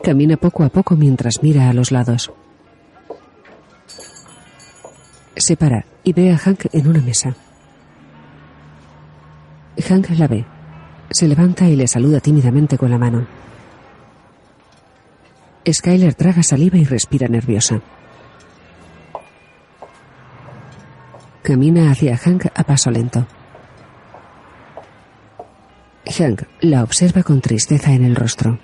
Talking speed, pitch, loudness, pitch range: 105 wpm, 135 Hz, -14 LUFS, 115-160 Hz